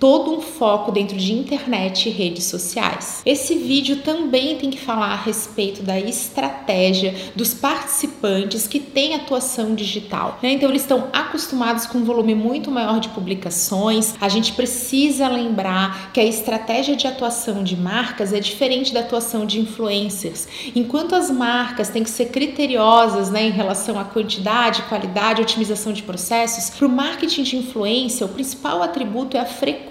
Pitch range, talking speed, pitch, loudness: 210-265 Hz, 165 wpm, 230 Hz, -19 LUFS